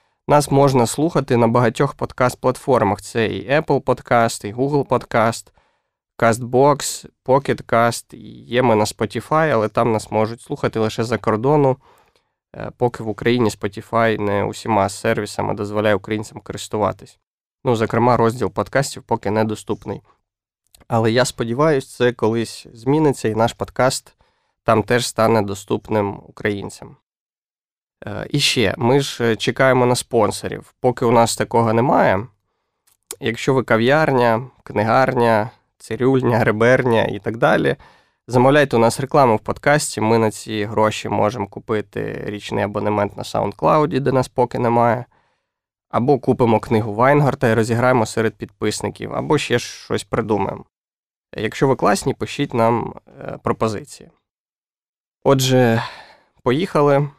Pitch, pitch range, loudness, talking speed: 115 Hz, 110-130 Hz, -18 LUFS, 125 wpm